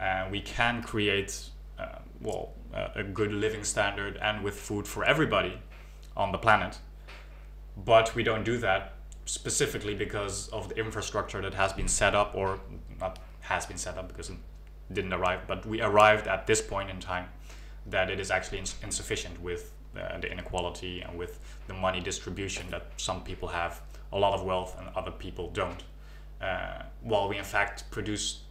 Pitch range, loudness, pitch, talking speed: 90-105 Hz, -30 LUFS, 95 Hz, 180 wpm